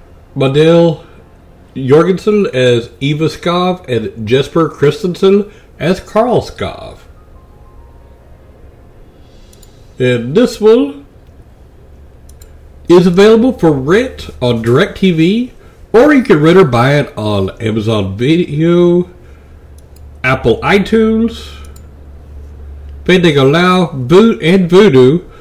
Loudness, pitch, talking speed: -10 LUFS, 130 Hz, 85 wpm